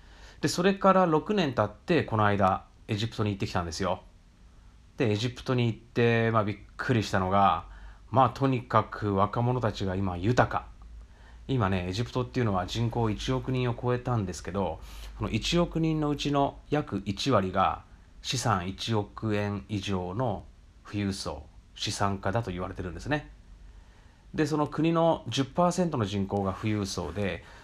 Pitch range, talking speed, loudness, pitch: 95-125 Hz, 285 characters per minute, -28 LUFS, 105 Hz